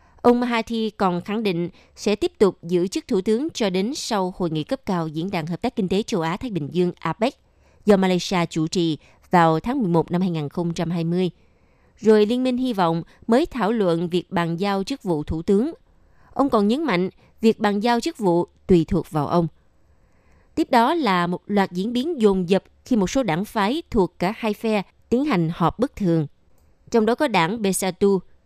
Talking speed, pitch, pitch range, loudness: 200 wpm, 195 Hz, 170-230 Hz, -22 LUFS